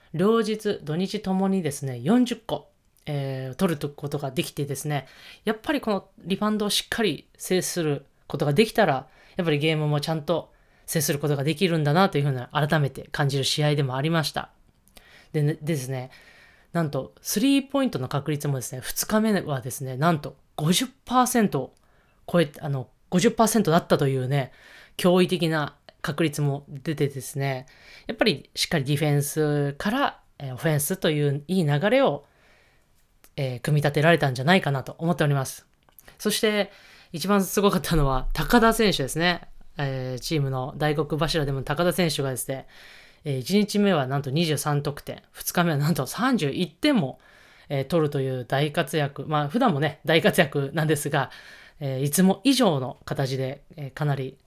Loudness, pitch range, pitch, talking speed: -25 LUFS, 140-185 Hz, 155 Hz, 310 characters per minute